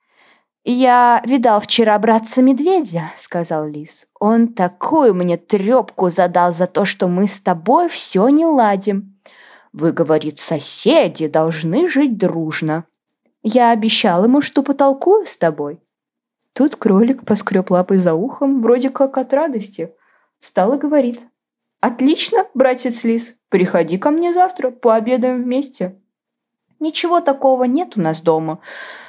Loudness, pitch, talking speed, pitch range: -15 LUFS, 230 Hz, 130 wpm, 180-270 Hz